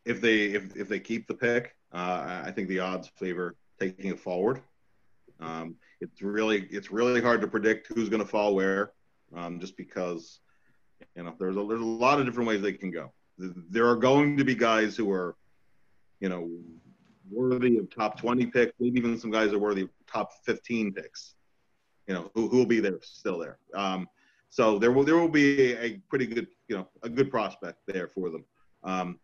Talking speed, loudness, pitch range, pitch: 205 wpm, -28 LUFS, 95-120 Hz, 105 Hz